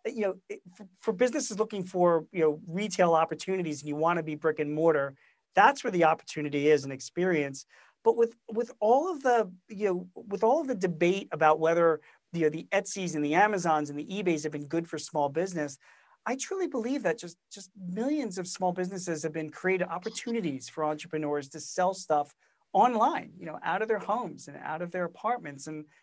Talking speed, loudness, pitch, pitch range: 205 wpm, -29 LUFS, 175 Hz, 155-205 Hz